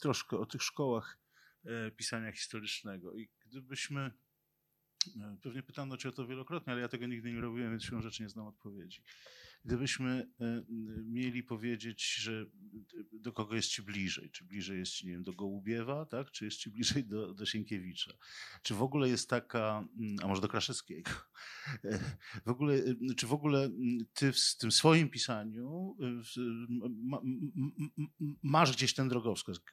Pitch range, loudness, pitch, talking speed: 110-135 Hz, -37 LUFS, 120 Hz, 145 wpm